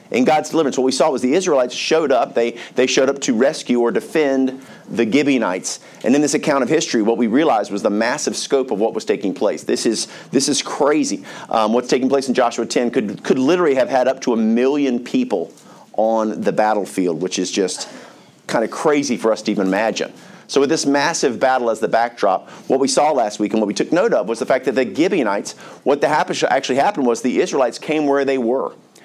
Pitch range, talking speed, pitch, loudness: 115-135 Hz, 230 wpm, 125 Hz, -18 LUFS